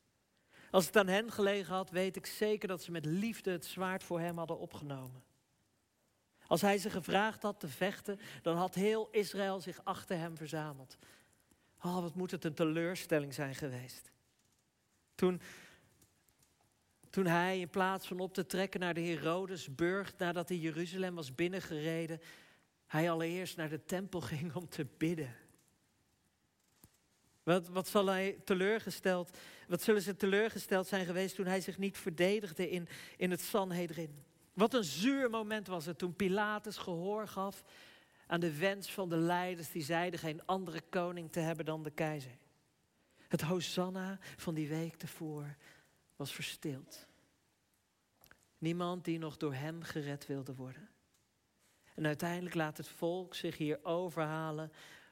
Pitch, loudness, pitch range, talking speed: 175 Hz, -37 LUFS, 160-190 Hz, 150 wpm